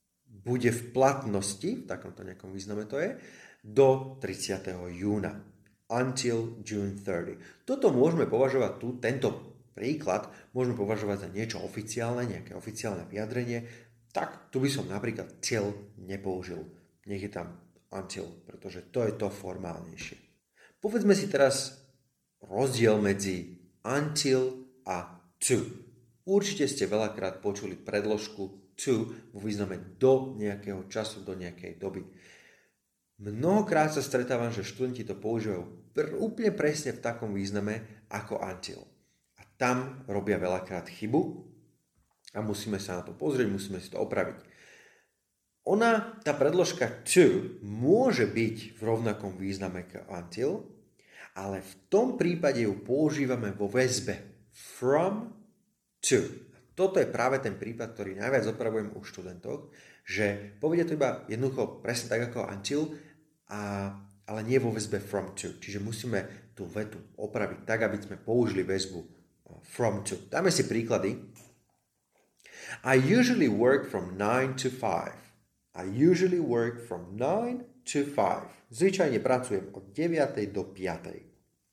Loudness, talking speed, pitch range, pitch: -30 LUFS, 130 wpm, 100-130 Hz, 110 Hz